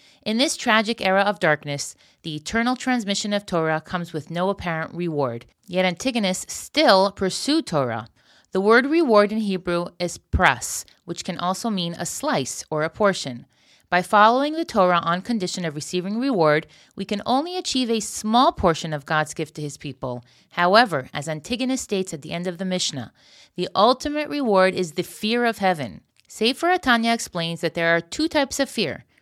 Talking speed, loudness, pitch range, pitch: 180 wpm, -22 LUFS, 165-230 Hz, 185 Hz